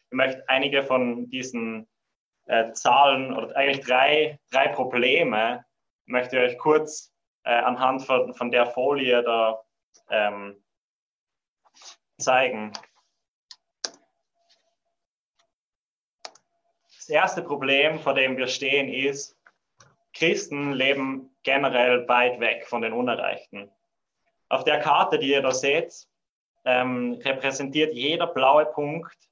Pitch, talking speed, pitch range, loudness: 135 Hz, 110 wpm, 125-145 Hz, -23 LUFS